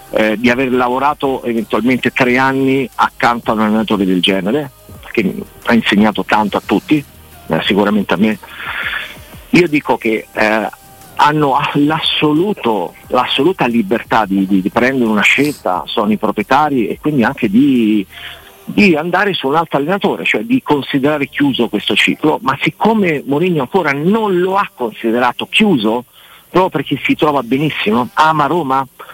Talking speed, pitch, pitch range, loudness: 145 wpm, 135 Hz, 110-150 Hz, -14 LUFS